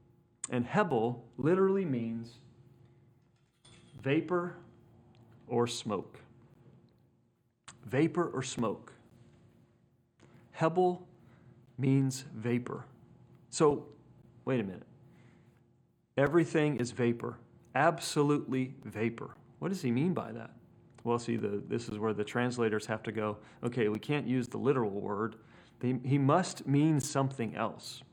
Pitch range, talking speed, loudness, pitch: 120-145 Hz, 110 wpm, -33 LUFS, 125 Hz